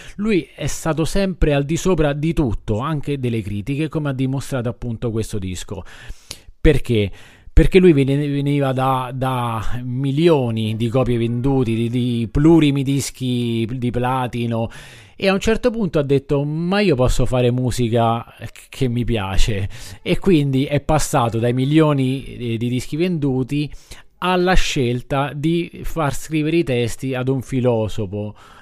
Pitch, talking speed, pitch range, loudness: 130 Hz, 145 wpm, 120-150 Hz, -19 LUFS